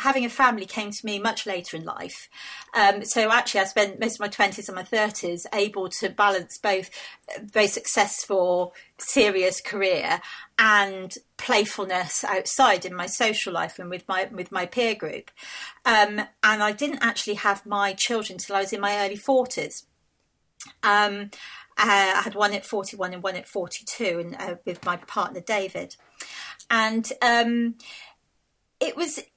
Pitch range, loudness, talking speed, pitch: 190-225 Hz, -23 LUFS, 170 wpm, 205 Hz